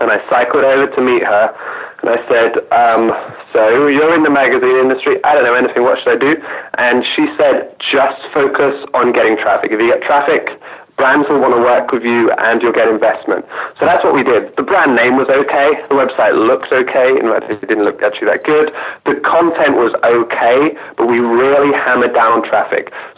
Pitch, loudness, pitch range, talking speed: 140 Hz, -12 LUFS, 130-155 Hz, 215 wpm